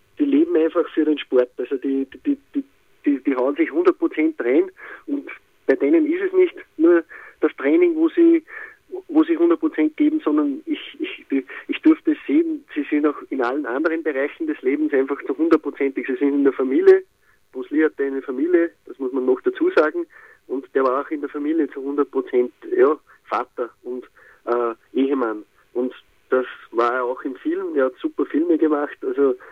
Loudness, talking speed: -21 LUFS, 190 wpm